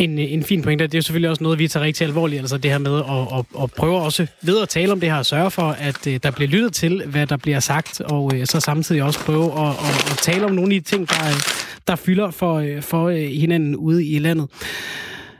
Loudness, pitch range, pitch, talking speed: -19 LUFS, 145-170 Hz, 155 Hz, 255 wpm